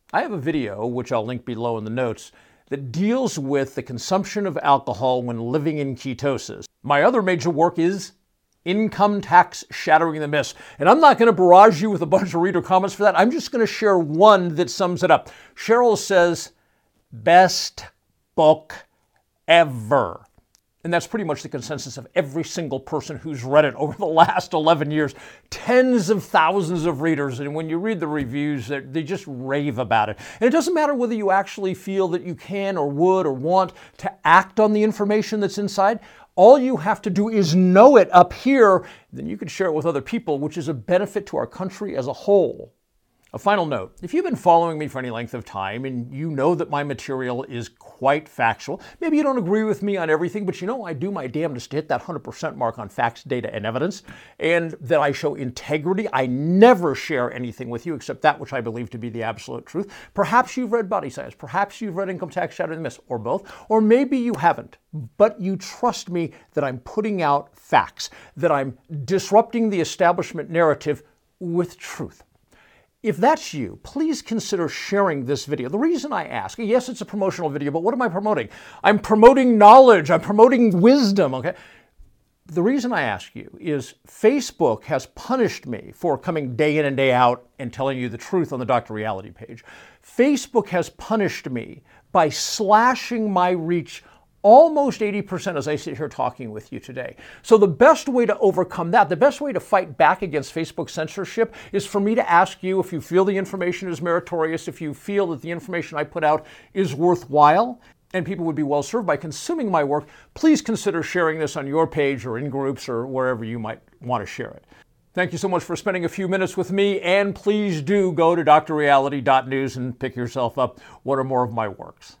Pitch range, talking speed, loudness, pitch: 145-205 Hz, 205 wpm, -20 LUFS, 175 Hz